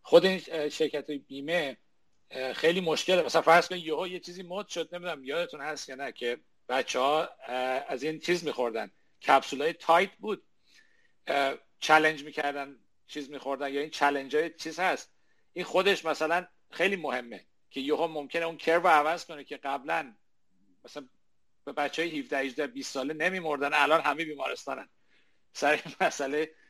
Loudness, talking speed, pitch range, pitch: -29 LUFS, 155 wpm, 140-175 Hz, 155 Hz